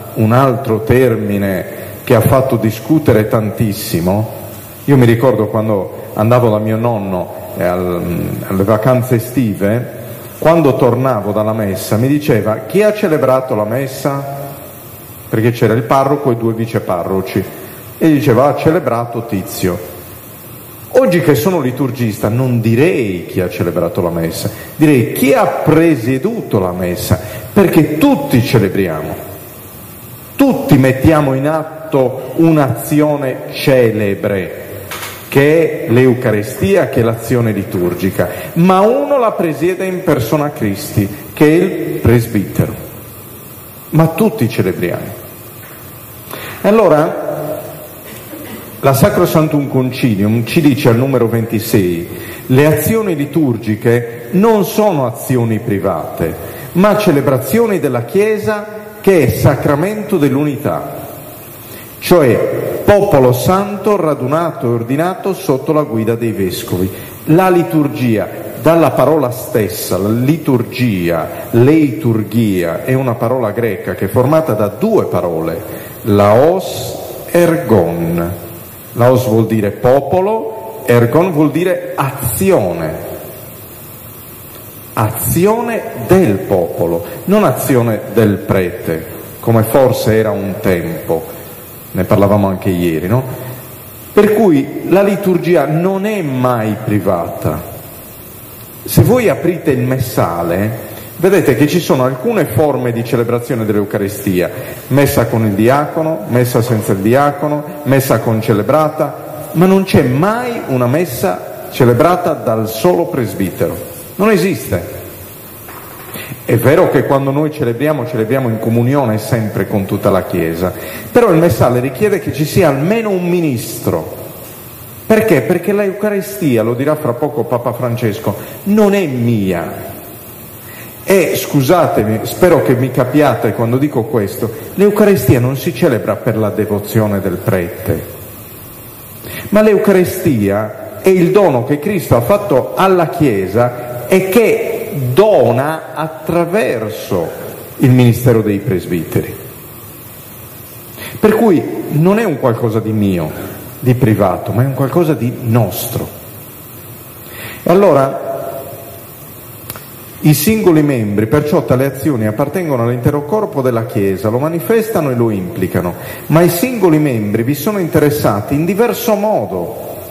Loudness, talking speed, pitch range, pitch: -13 LUFS, 120 wpm, 110-155 Hz, 125 Hz